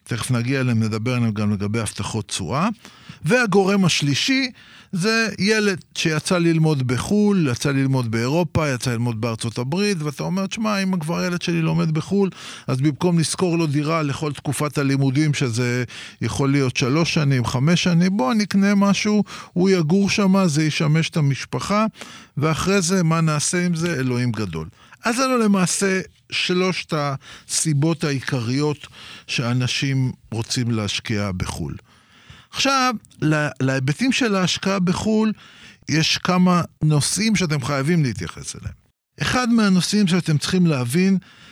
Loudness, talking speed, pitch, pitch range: -20 LUFS, 135 wpm, 155 Hz, 130-190 Hz